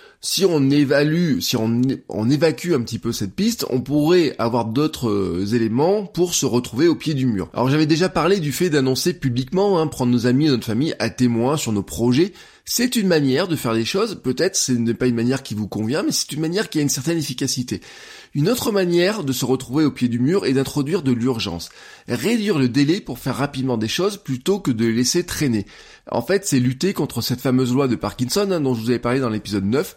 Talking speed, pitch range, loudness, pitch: 230 wpm, 120-165 Hz, -20 LUFS, 135 Hz